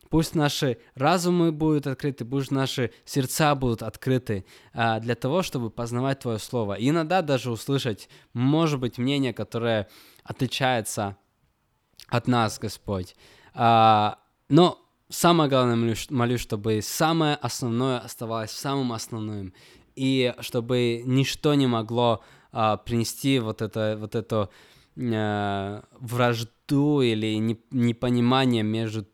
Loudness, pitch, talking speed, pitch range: -25 LUFS, 120 Hz, 110 wpm, 110-135 Hz